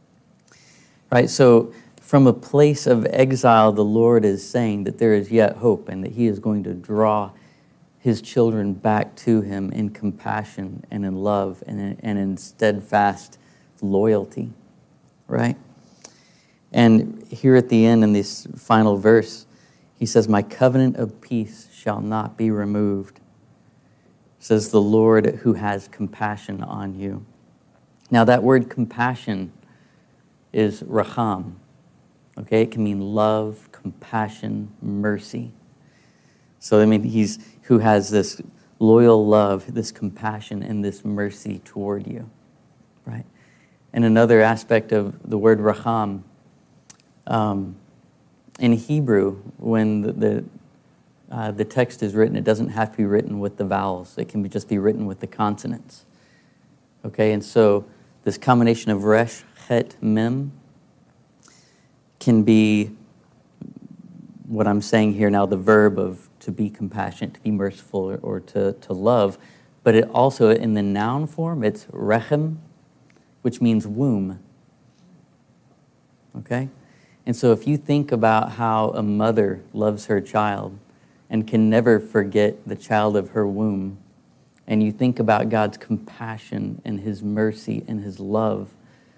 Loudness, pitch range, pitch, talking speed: -20 LUFS, 105-115 Hz, 110 Hz, 140 wpm